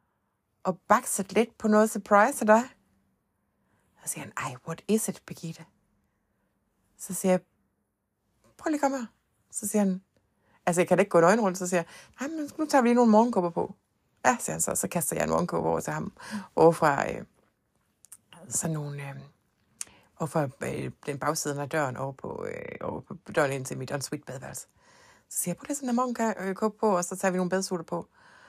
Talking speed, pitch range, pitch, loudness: 185 wpm, 135-215 Hz, 180 Hz, -27 LUFS